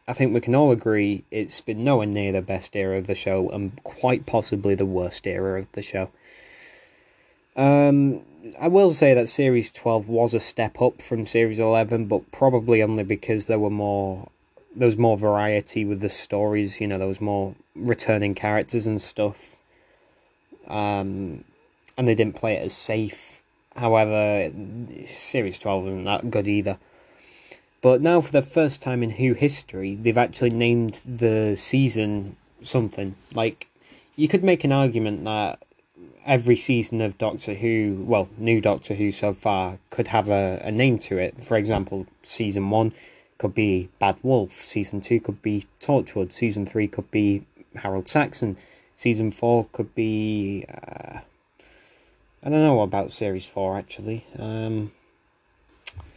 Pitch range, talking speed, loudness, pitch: 100-120 Hz, 160 wpm, -23 LUFS, 110 Hz